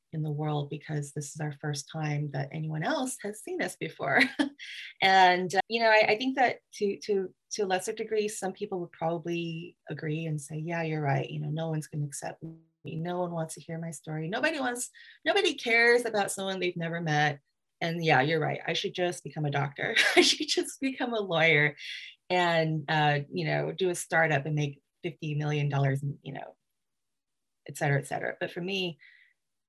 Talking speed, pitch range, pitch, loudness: 200 wpm, 150-195 Hz, 165 Hz, -29 LUFS